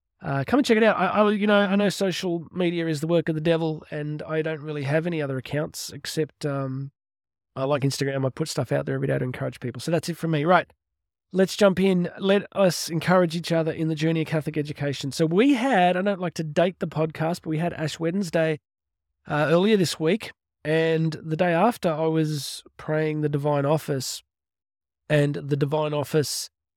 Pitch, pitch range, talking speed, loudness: 160 Hz, 145-175 Hz, 210 wpm, -24 LUFS